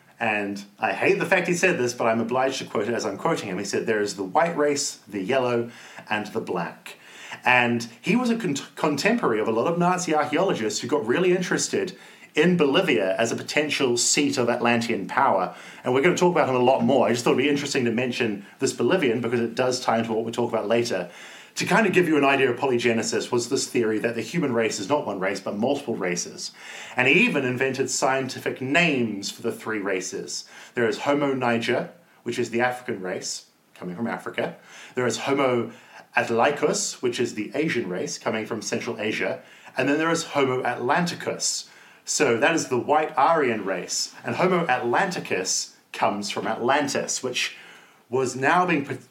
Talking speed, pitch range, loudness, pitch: 205 wpm, 115-145 Hz, -23 LUFS, 125 Hz